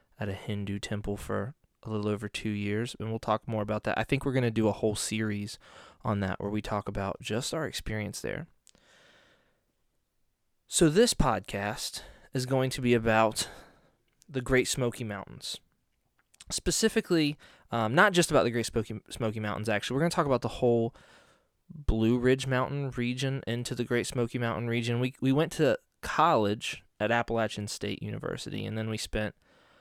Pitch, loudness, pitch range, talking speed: 115 Hz, -30 LUFS, 105-130 Hz, 175 wpm